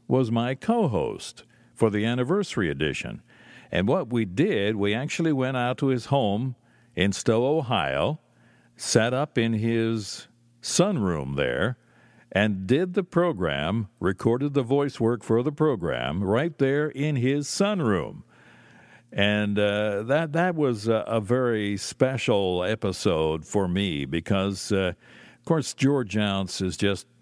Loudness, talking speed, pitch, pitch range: -25 LUFS, 140 wpm, 115 Hz, 100-135 Hz